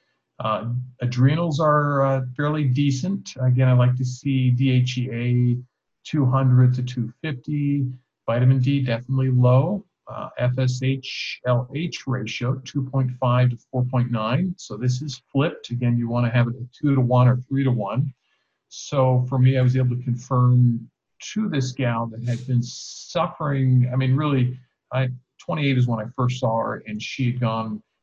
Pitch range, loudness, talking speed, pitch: 125-135 Hz, -22 LUFS, 160 wpm, 130 Hz